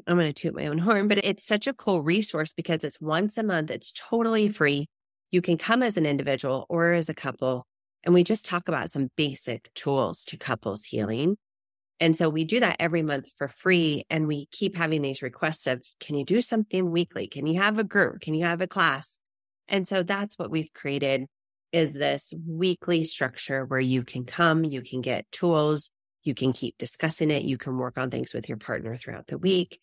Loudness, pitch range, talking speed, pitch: -26 LUFS, 135-180 Hz, 215 wpm, 160 Hz